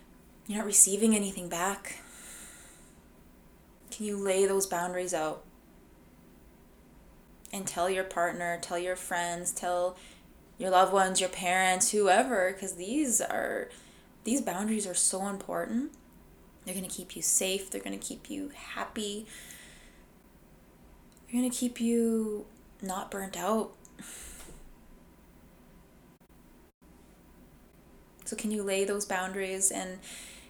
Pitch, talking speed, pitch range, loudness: 190 Hz, 120 wpm, 180-215 Hz, -30 LUFS